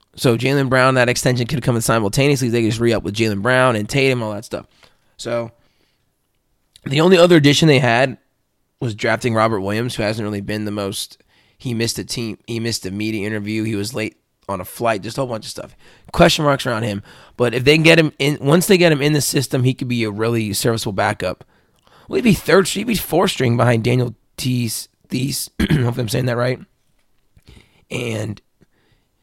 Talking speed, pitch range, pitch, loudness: 215 wpm, 110-135 Hz, 120 Hz, -17 LUFS